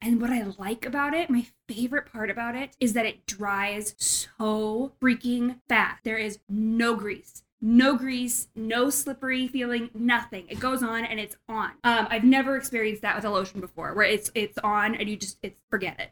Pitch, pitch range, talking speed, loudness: 230 Hz, 210-245 Hz, 195 wpm, -26 LUFS